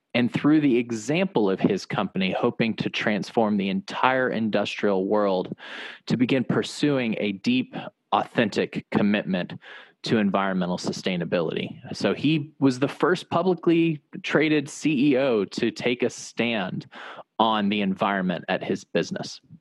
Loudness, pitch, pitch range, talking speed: -24 LUFS, 135 Hz, 105-160 Hz, 130 wpm